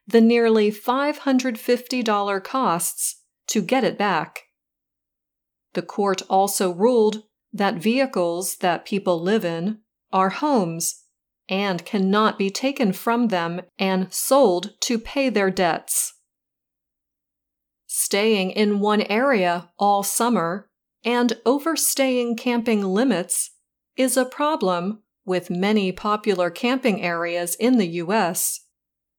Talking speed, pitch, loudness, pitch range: 110 wpm, 210 Hz, -21 LUFS, 185-240 Hz